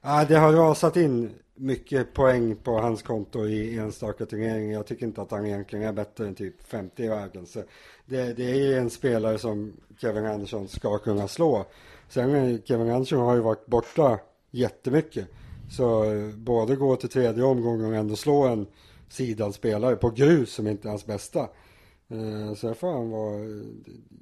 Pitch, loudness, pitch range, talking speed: 115 Hz, -26 LUFS, 105-125 Hz, 165 wpm